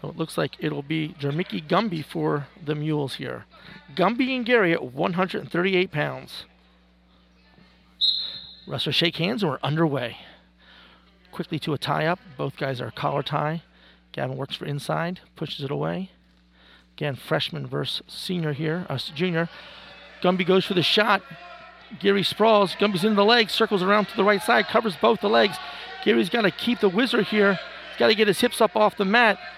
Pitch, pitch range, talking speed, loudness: 170 Hz, 145-205 Hz, 175 wpm, -23 LUFS